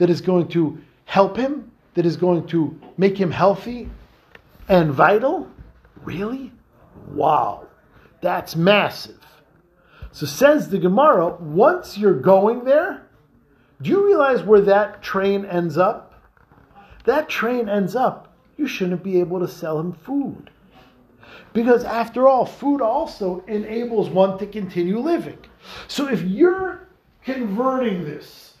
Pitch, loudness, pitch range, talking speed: 200 Hz, -19 LUFS, 175-245 Hz, 130 wpm